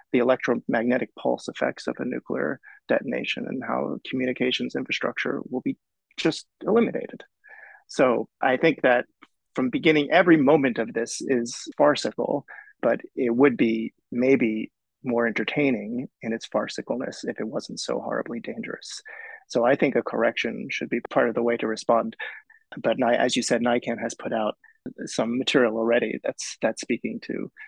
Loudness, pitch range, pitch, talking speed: -25 LUFS, 115-145 Hz, 125 Hz, 155 wpm